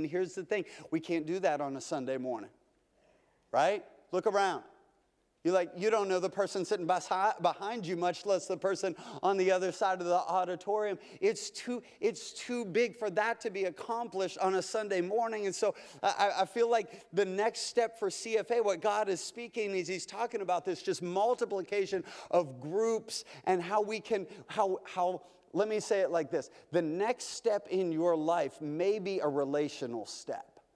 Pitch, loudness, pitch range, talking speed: 195 Hz, -33 LUFS, 180-220 Hz, 190 wpm